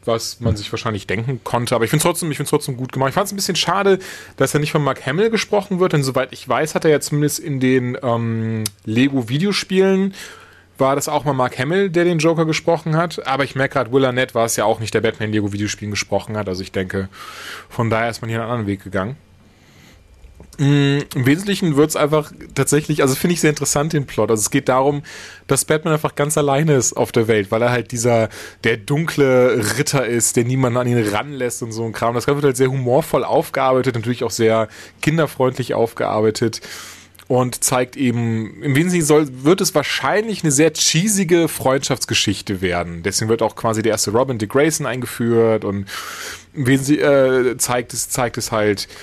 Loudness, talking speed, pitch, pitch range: -18 LUFS, 210 wpm, 130 Hz, 115-150 Hz